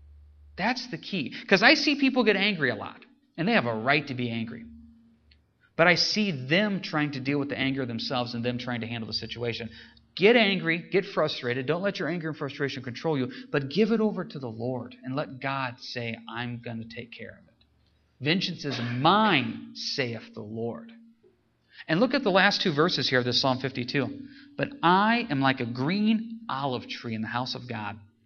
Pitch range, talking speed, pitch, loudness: 120-195 Hz, 210 wpm, 135 Hz, -26 LUFS